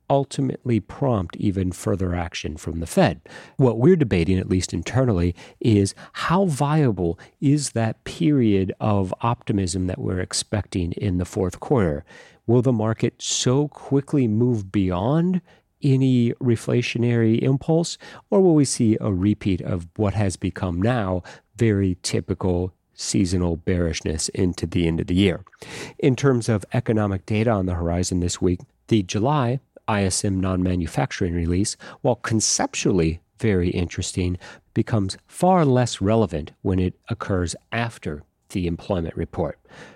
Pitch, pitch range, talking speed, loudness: 105 Hz, 90-125 Hz, 135 wpm, -22 LUFS